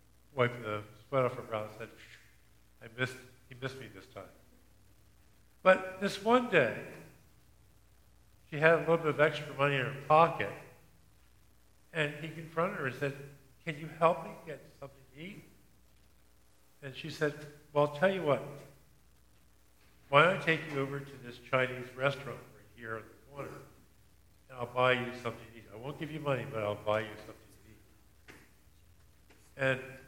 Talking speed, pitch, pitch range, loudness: 175 wpm, 130 Hz, 105-150 Hz, -32 LUFS